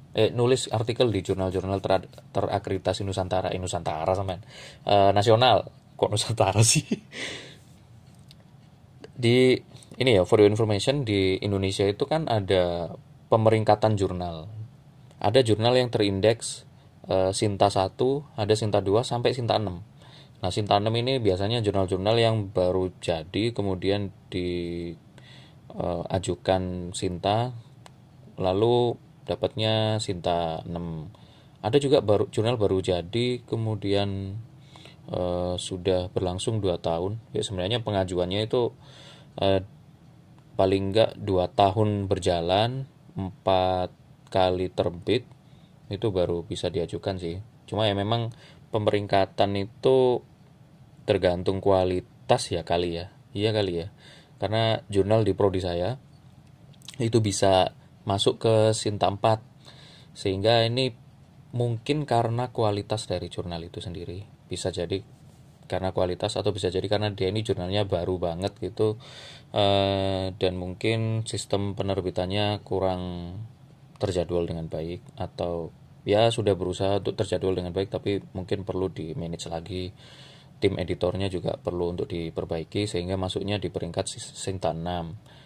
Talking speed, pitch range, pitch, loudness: 120 wpm, 95-120 Hz, 105 Hz, -26 LUFS